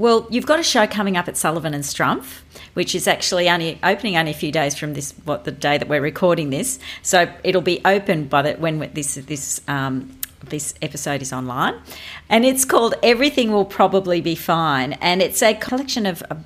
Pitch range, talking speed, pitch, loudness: 150-195 Hz, 210 wpm, 170 Hz, -19 LUFS